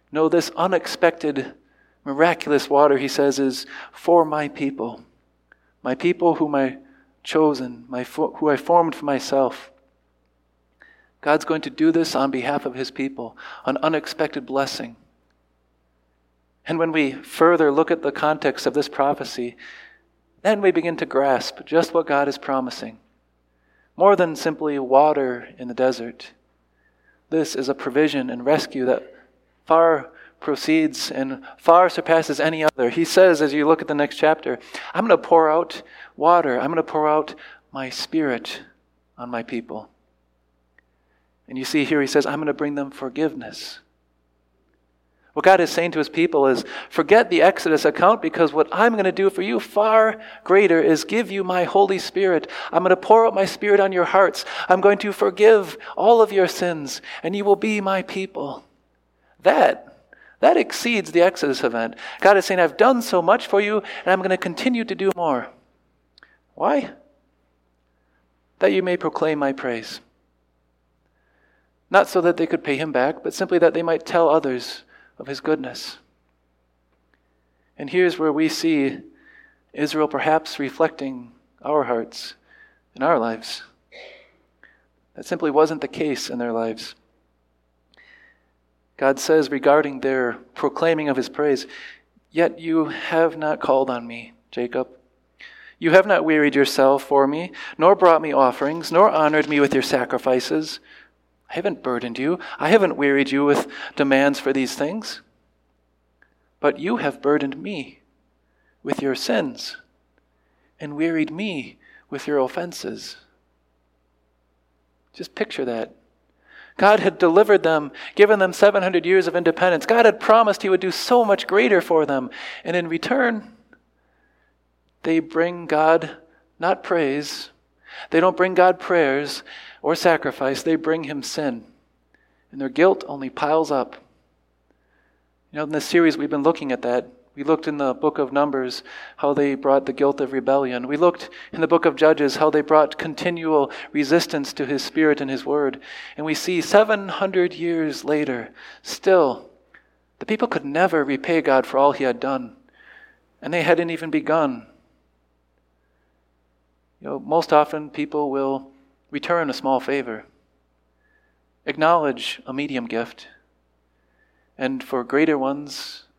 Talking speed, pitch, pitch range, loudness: 155 wpm, 145 Hz, 125-170 Hz, -20 LUFS